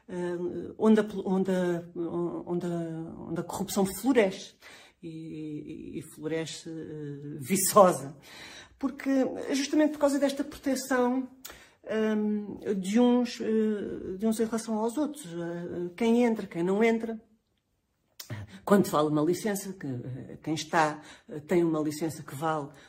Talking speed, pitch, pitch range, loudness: 130 wpm, 185 Hz, 160-225 Hz, -29 LUFS